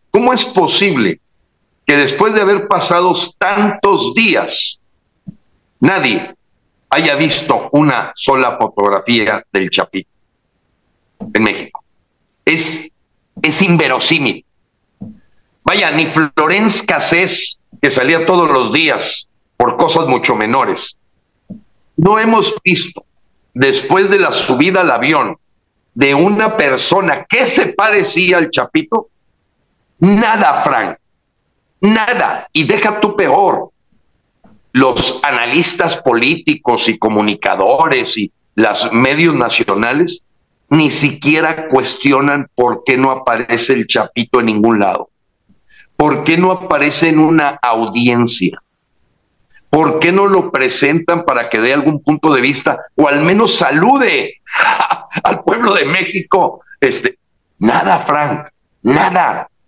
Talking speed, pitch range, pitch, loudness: 115 wpm, 140-200 Hz, 160 Hz, -12 LUFS